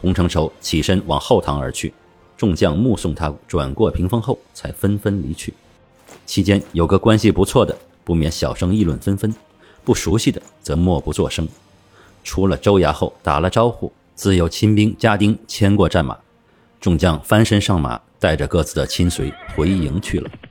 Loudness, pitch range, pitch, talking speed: -18 LUFS, 80-105 Hz, 90 Hz, 255 characters per minute